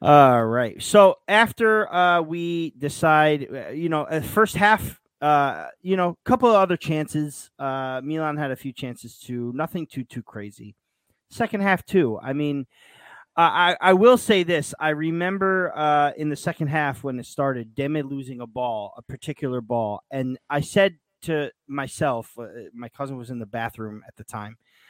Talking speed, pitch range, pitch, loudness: 175 wpm, 125-170 Hz, 145 Hz, -22 LUFS